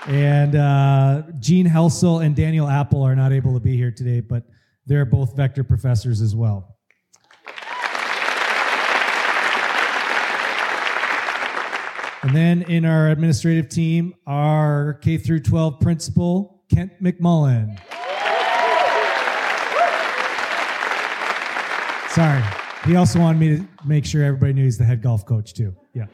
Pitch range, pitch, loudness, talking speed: 125-160 Hz, 145 Hz, -19 LUFS, 110 wpm